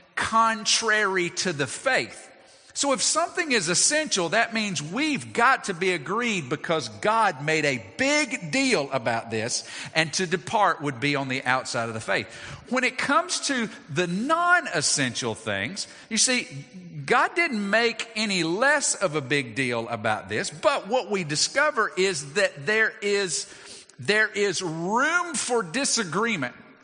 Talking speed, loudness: 155 wpm, -24 LUFS